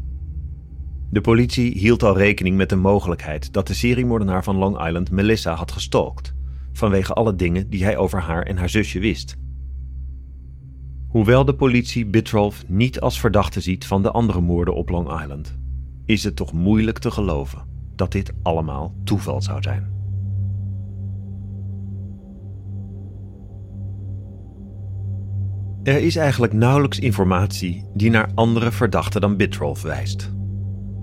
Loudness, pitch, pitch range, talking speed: -20 LUFS, 100 Hz, 85-105 Hz, 130 wpm